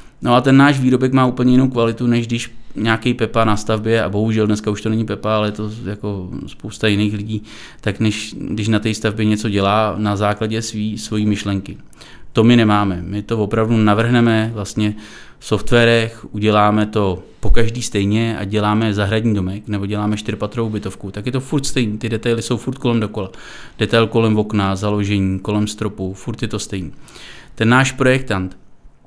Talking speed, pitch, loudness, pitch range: 185 wpm, 110 Hz, -17 LUFS, 105-115 Hz